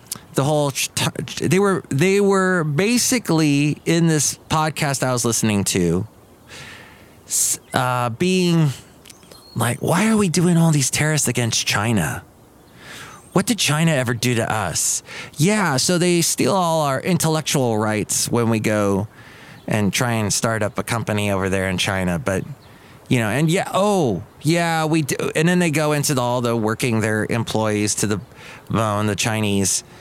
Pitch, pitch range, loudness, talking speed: 130 Hz, 110-160 Hz, -19 LUFS, 160 wpm